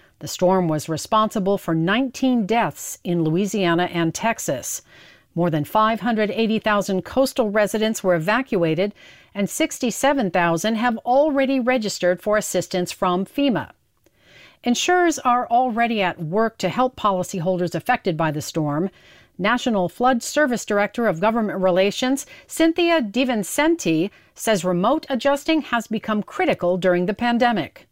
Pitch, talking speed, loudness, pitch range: 215 Hz, 120 wpm, -21 LUFS, 180-245 Hz